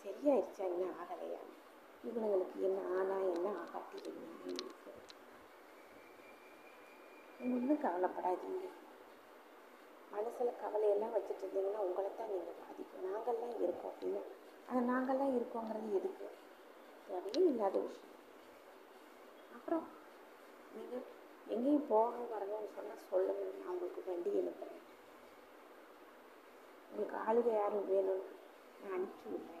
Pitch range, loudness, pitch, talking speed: 195-280 Hz, -39 LUFS, 220 Hz, 85 wpm